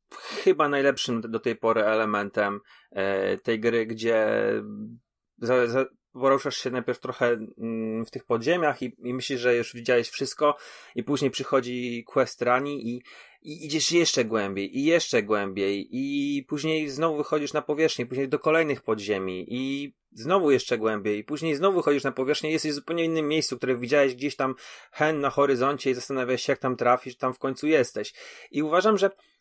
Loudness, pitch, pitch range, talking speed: -26 LUFS, 130 Hz, 115-150 Hz, 170 wpm